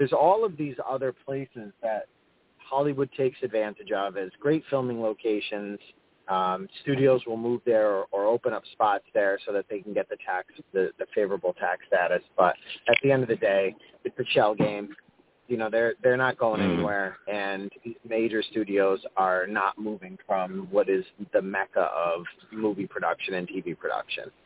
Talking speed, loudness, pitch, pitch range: 180 wpm, -27 LUFS, 120 Hz, 105-160 Hz